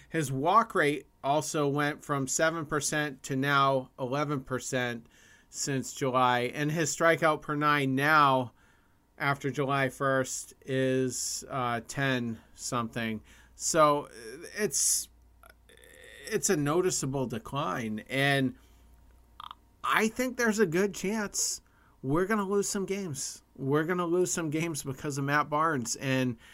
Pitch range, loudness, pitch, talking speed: 125-165 Hz, -29 LUFS, 140 Hz, 120 wpm